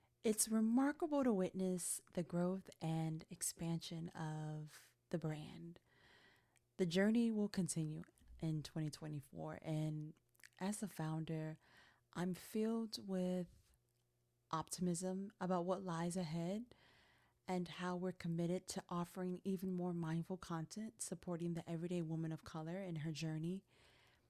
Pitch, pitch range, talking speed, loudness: 175 Hz, 160-185 Hz, 120 wpm, -43 LUFS